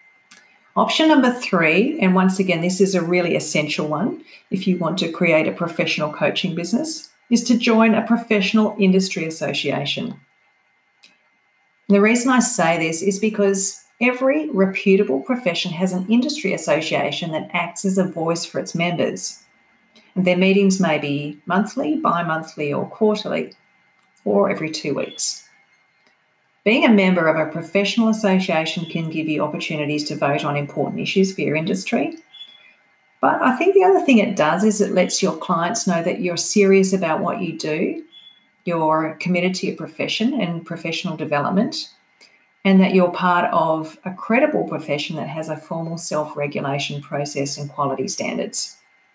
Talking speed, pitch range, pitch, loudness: 160 wpm, 160-210 Hz, 180 Hz, -19 LUFS